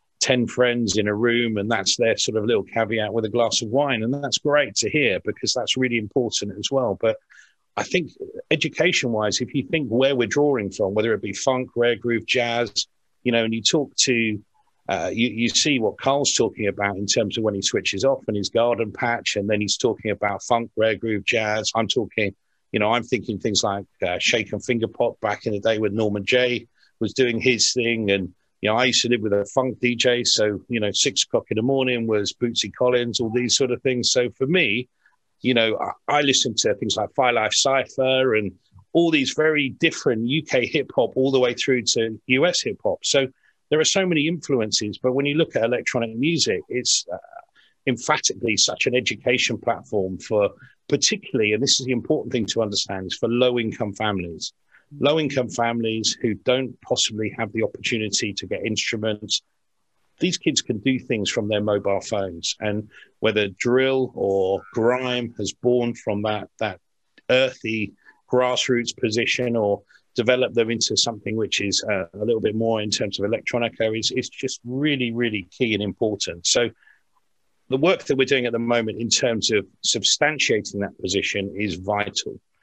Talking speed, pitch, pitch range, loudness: 195 wpm, 115 Hz, 105-130 Hz, -22 LUFS